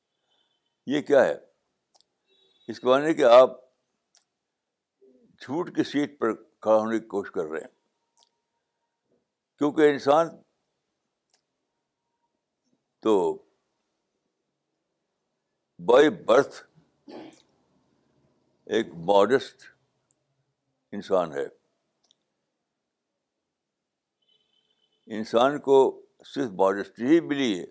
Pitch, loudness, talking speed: 145 Hz, -23 LUFS, 75 wpm